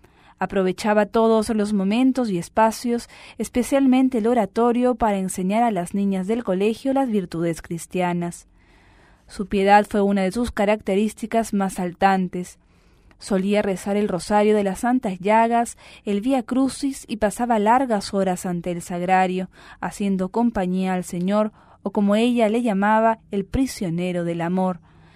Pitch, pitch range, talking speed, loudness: 205 Hz, 185-230 Hz, 140 wpm, -21 LUFS